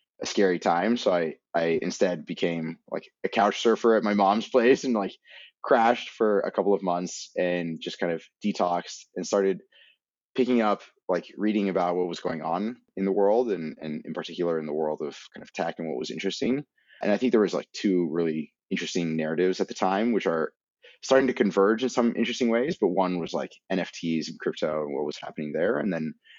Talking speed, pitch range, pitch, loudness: 215 wpm, 85-105 Hz, 90 Hz, -26 LUFS